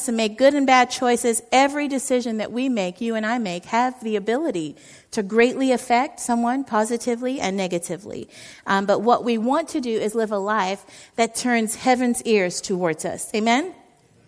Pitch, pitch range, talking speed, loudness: 235 Hz, 210-250 Hz, 180 wpm, -21 LUFS